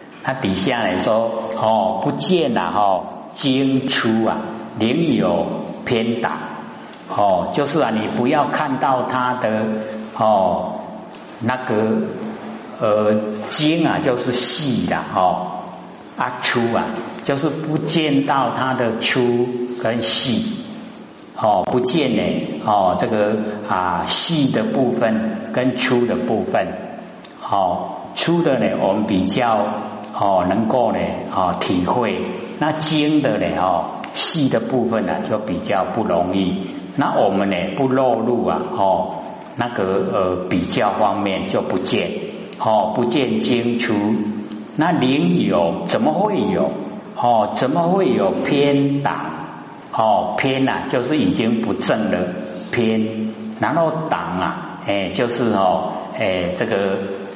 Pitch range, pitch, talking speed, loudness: 110-140 Hz, 115 Hz, 170 characters per minute, -19 LUFS